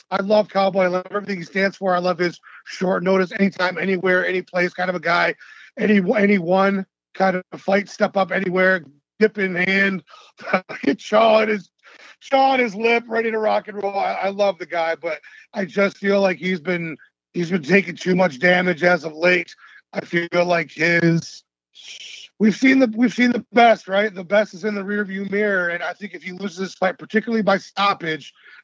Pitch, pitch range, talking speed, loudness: 190 Hz, 180-205 Hz, 200 wpm, -19 LUFS